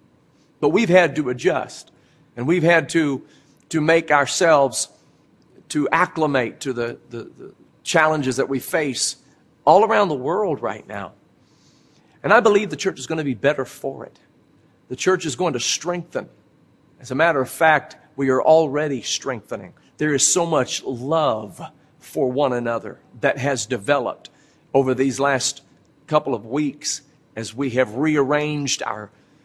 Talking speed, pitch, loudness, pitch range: 155 wpm, 145 Hz, -20 LUFS, 130-155 Hz